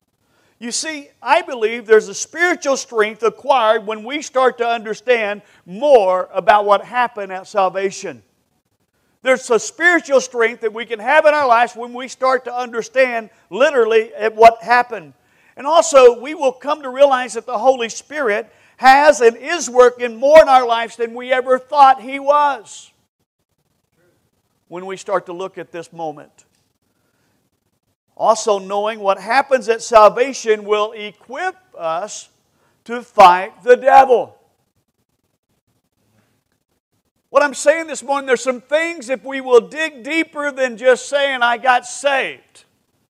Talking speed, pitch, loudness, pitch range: 145 wpm, 240 Hz, -15 LUFS, 210-270 Hz